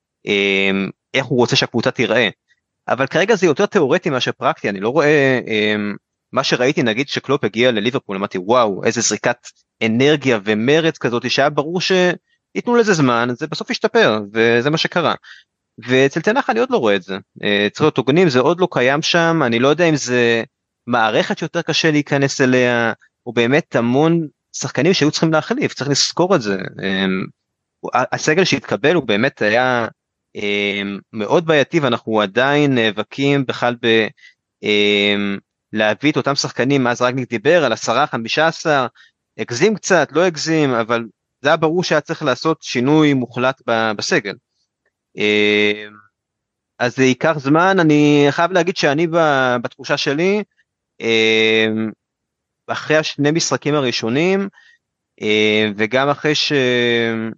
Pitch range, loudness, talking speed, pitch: 110-155 Hz, -16 LUFS, 130 wpm, 130 Hz